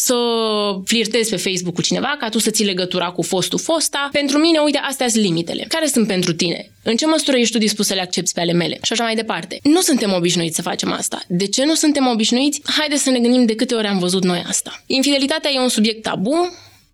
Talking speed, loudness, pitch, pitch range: 235 wpm, -17 LUFS, 225 Hz, 190-280 Hz